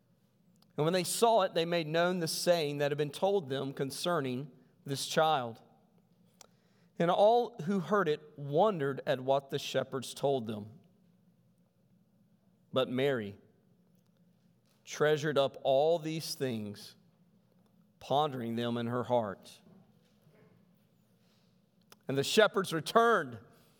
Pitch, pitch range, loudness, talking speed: 170 Hz, 140-185 Hz, -31 LUFS, 115 wpm